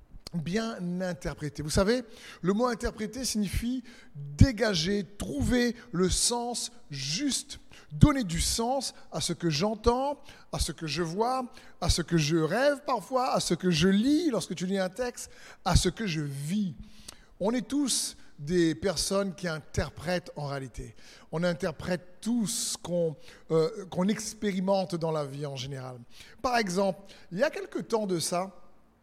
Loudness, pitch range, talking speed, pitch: -29 LUFS, 165-235 Hz, 160 wpm, 190 Hz